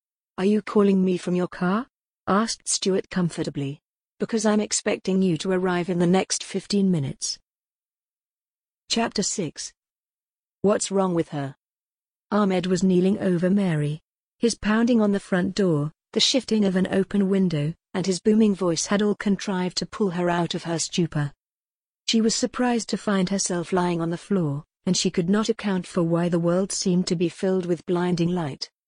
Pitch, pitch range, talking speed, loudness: 185 Hz, 175-205 Hz, 175 wpm, -23 LUFS